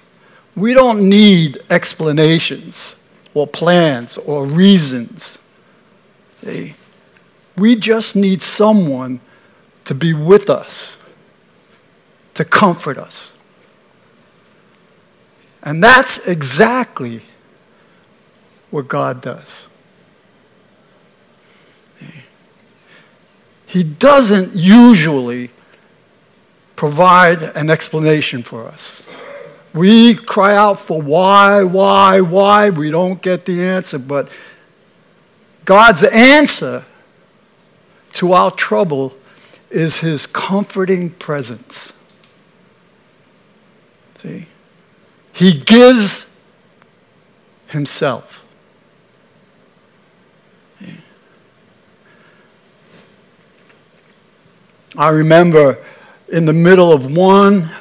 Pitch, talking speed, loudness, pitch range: 195 Hz, 70 wpm, -11 LUFS, 160-210 Hz